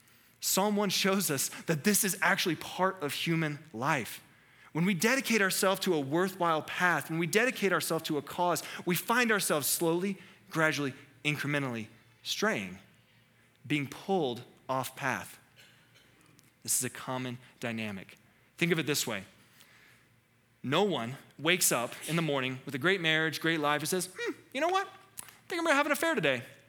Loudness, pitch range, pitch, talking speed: -30 LUFS, 135-190 Hz, 160 Hz, 170 wpm